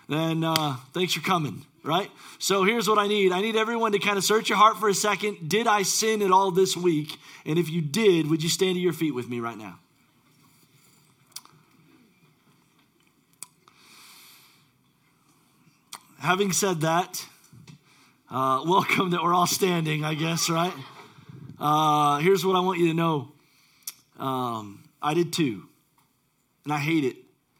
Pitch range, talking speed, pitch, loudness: 150-190 Hz, 155 wpm, 165 Hz, -24 LUFS